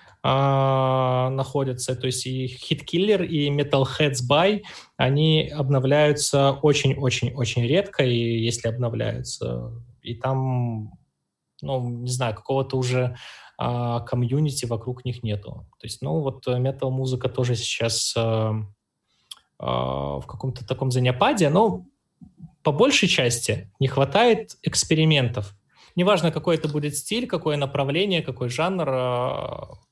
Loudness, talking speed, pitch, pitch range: -23 LUFS, 125 wpm, 130 Hz, 120-150 Hz